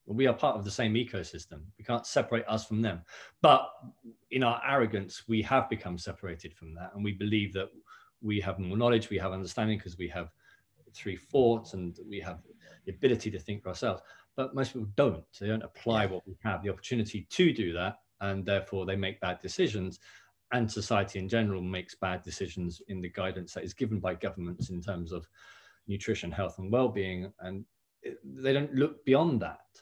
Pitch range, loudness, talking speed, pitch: 95-115 Hz, -32 LUFS, 195 wpm, 100 Hz